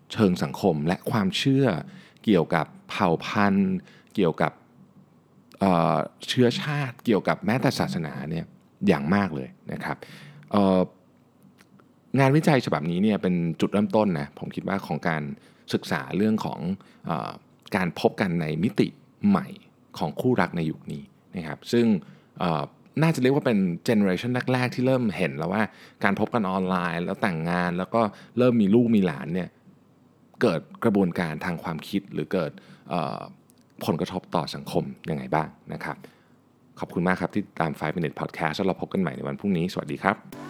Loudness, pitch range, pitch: -25 LUFS, 95-145 Hz, 115 Hz